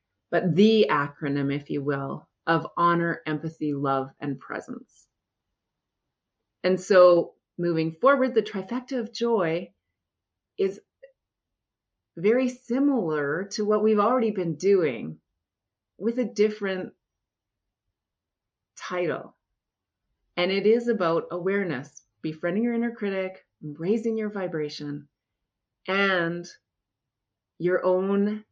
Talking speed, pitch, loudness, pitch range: 100 wpm, 170 Hz, -25 LUFS, 130-205 Hz